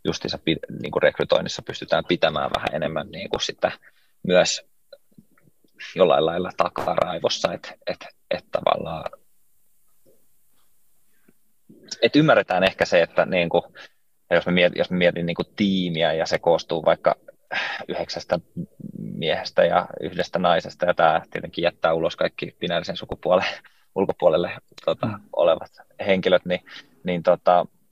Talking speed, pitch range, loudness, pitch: 120 wpm, 90-105 Hz, -22 LUFS, 90 Hz